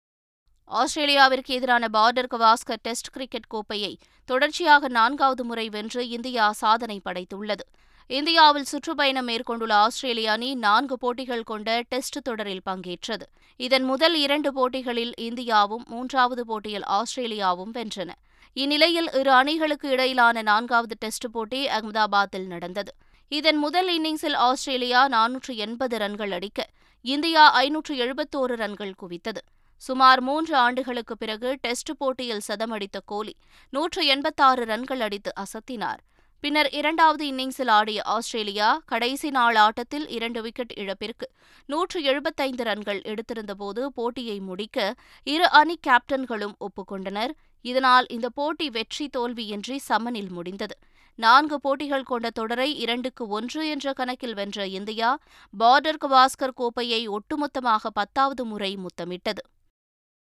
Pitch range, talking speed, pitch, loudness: 215-270 Hz, 115 wpm, 245 Hz, -23 LUFS